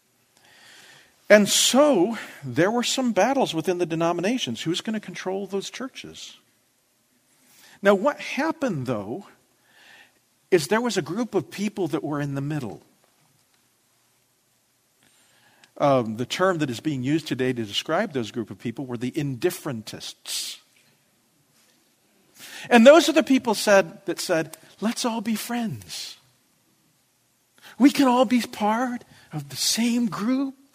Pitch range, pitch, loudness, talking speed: 145-240 Hz, 190 Hz, -23 LUFS, 135 wpm